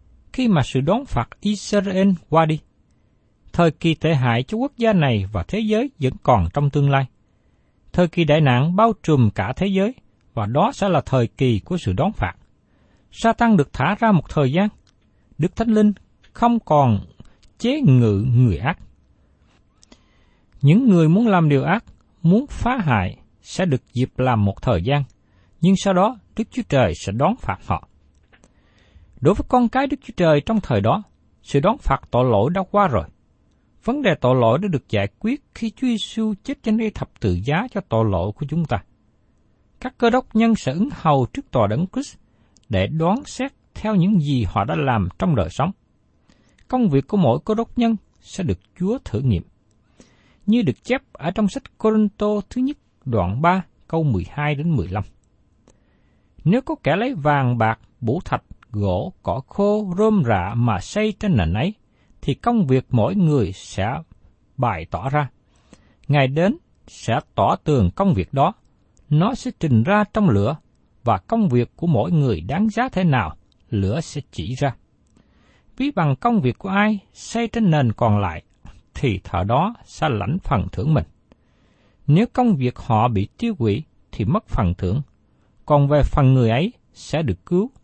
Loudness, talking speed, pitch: -20 LUFS, 185 wpm, 150 Hz